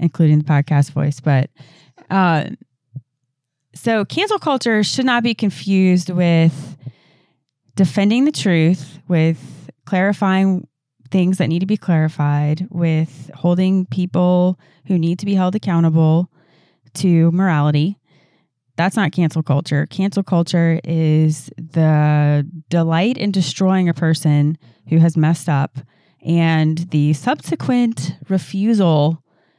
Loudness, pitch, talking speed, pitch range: -17 LUFS, 165 Hz, 115 wpm, 150-185 Hz